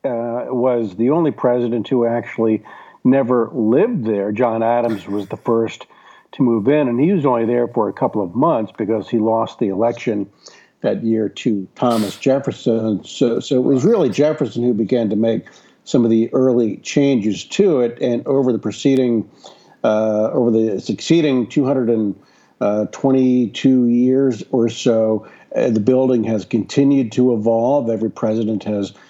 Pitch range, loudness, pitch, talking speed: 110-130 Hz, -17 LUFS, 120 Hz, 165 wpm